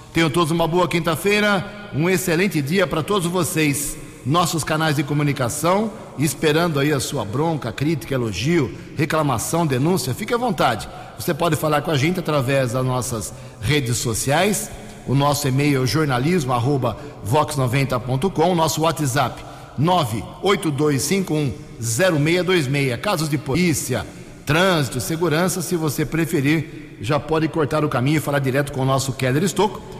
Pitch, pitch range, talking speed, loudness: 155 Hz, 135-170 Hz, 135 wpm, -20 LUFS